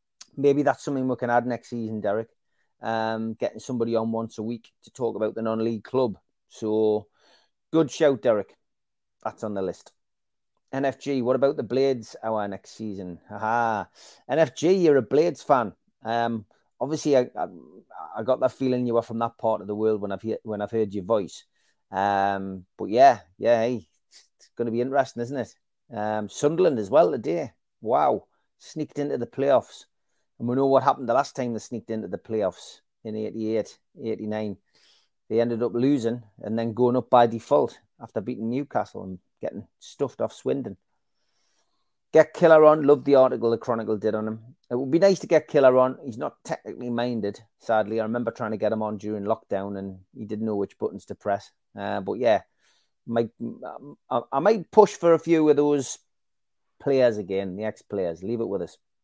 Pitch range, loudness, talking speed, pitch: 110-130 Hz, -25 LUFS, 190 wpm, 115 Hz